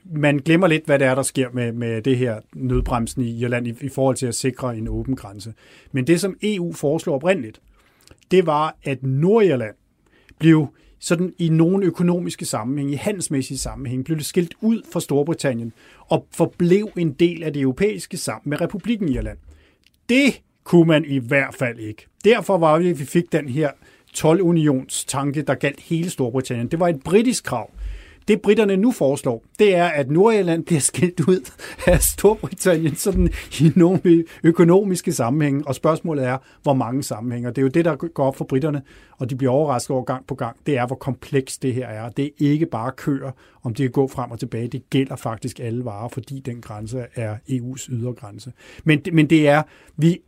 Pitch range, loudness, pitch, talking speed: 130-170 Hz, -20 LUFS, 140 Hz, 195 wpm